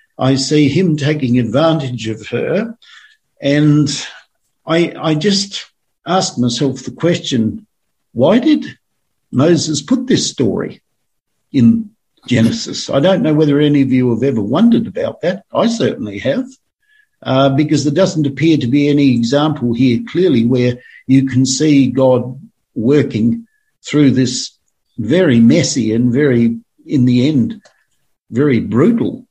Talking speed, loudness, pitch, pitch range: 135 wpm, -14 LUFS, 145 Hz, 130-185 Hz